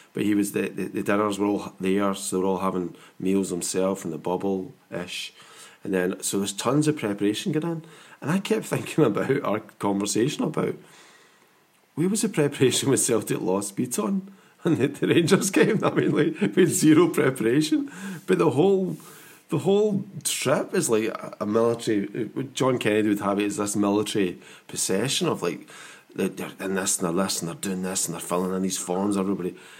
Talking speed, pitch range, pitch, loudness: 195 wpm, 95-155 Hz, 105 Hz, -24 LUFS